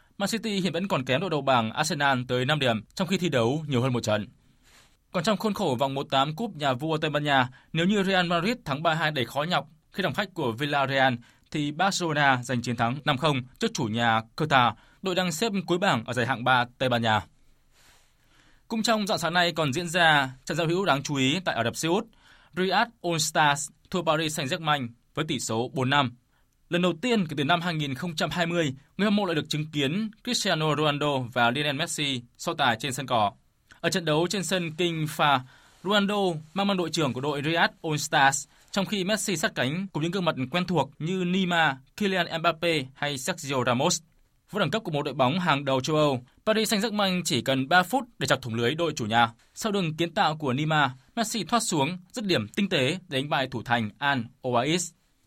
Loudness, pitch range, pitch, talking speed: -26 LUFS, 135-180 Hz, 155 Hz, 220 wpm